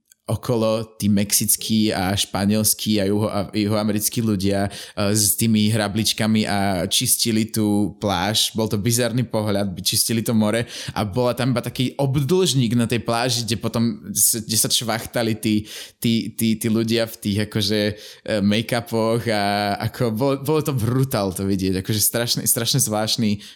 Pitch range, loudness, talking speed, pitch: 105-115 Hz, -20 LUFS, 150 wpm, 110 Hz